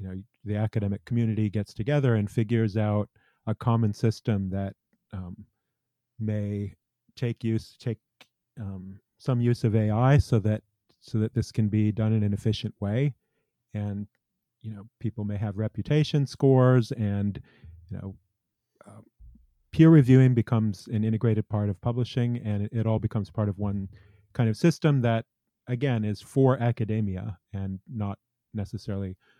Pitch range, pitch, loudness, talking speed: 105-120 Hz, 110 Hz, -26 LUFS, 155 wpm